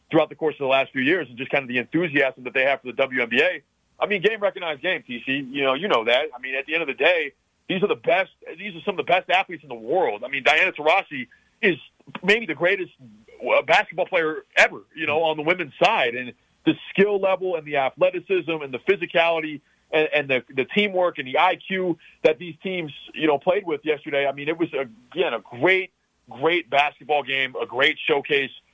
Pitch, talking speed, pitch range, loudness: 160 Hz, 230 wpm, 135-180 Hz, -22 LUFS